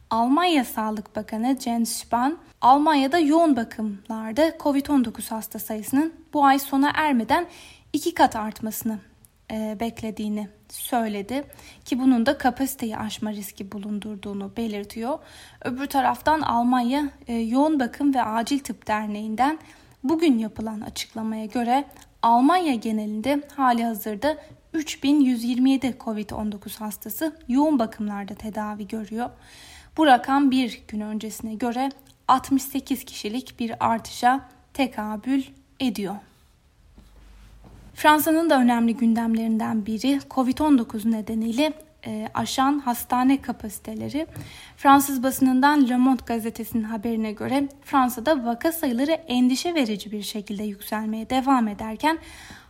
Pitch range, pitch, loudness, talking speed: 220-275 Hz, 245 Hz, -23 LUFS, 105 wpm